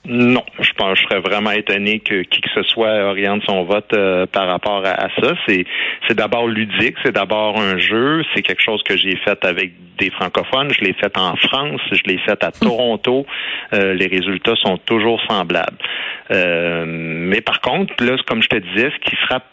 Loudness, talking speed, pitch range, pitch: -16 LUFS, 205 wpm, 95-120 Hz, 105 Hz